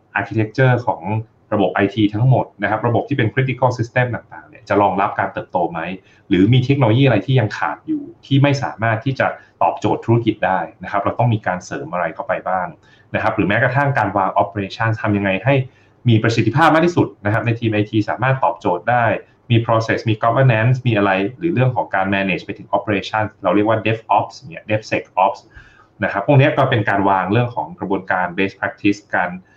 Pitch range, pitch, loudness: 100-130 Hz, 110 Hz, -18 LUFS